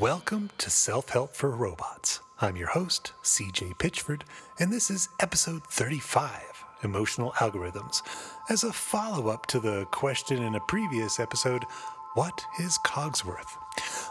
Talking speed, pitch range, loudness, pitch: 135 wpm, 130-175 Hz, -29 LUFS, 150 Hz